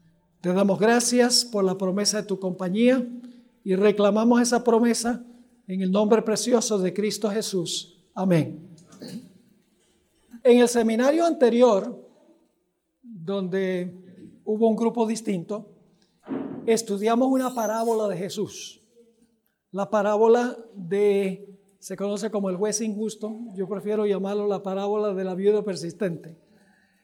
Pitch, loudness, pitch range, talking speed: 210 Hz, -23 LUFS, 195-230 Hz, 120 wpm